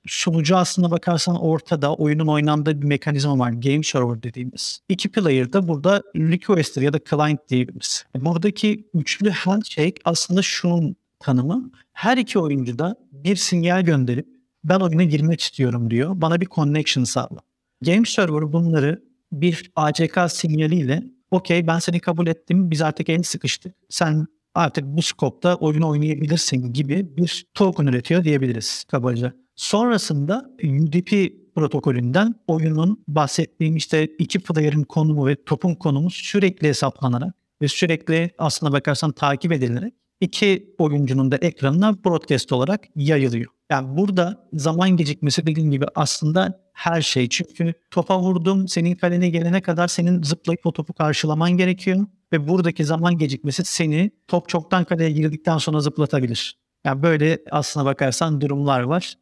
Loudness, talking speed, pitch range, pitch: -20 LUFS, 140 wpm, 150-180 Hz, 165 Hz